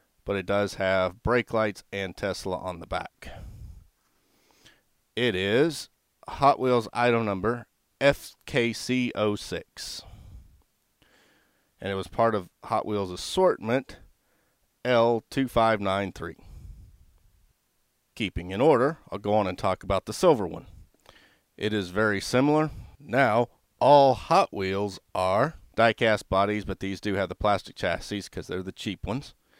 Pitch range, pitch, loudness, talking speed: 95-115 Hz, 100 Hz, -26 LUFS, 130 wpm